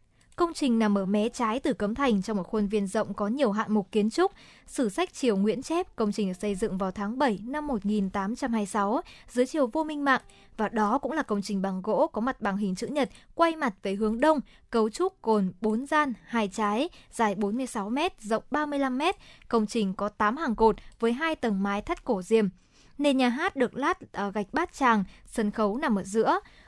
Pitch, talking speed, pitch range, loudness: 225 Hz, 220 wpm, 210-275 Hz, -28 LUFS